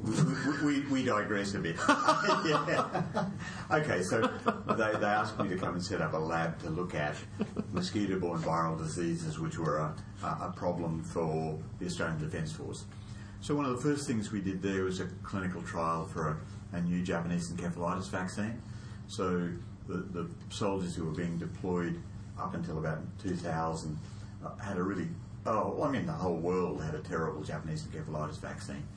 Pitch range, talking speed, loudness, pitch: 85-105 Hz, 175 wpm, -34 LUFS, 90 Hz